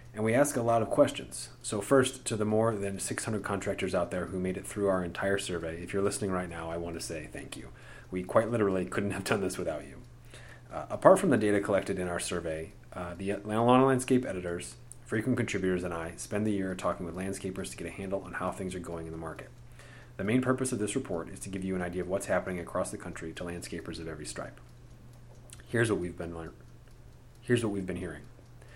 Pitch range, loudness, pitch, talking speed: 90-120 Hz, -31 LUFS, 100 Hz, 235 wpm